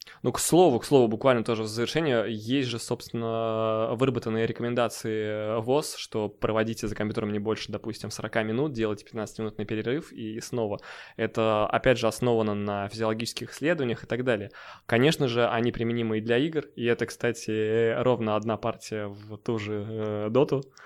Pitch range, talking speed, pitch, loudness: 110-120 Hz, 160 wpm, 115 Hz, -27 LUFS